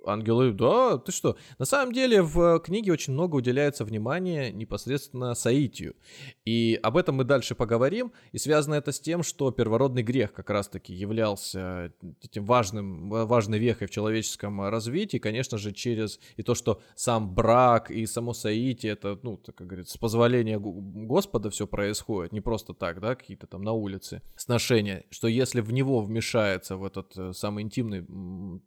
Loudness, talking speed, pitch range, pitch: -27 LUFS, 165 wpm, 105-130 Hz, 115 Hz